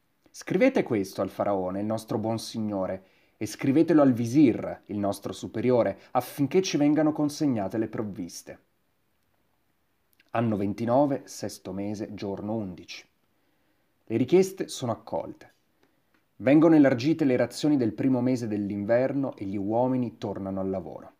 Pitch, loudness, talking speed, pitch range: 115 Hz, -26 LUFS, 125 wpm, 100-130 Hz